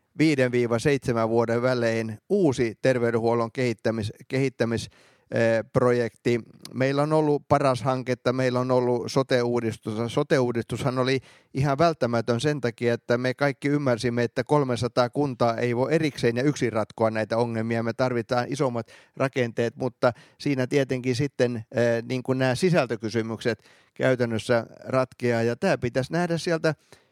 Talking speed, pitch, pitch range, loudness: 125 wpm, 125 Hz, 115-135 Hz, -25 LUFS